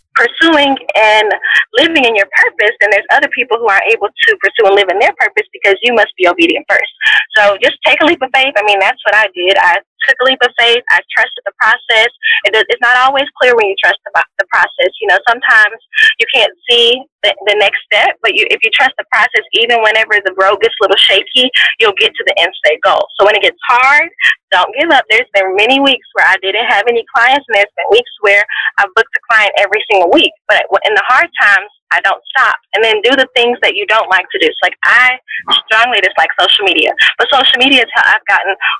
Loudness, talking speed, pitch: -9 LUFS, 240 wpm, 255 Hz